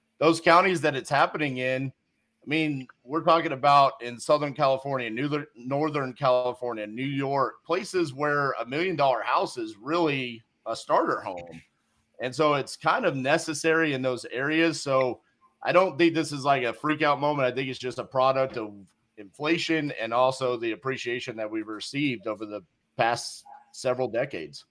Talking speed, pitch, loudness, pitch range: 170 wpm, 140 Hz, -26 LUFS, 125-160 Hz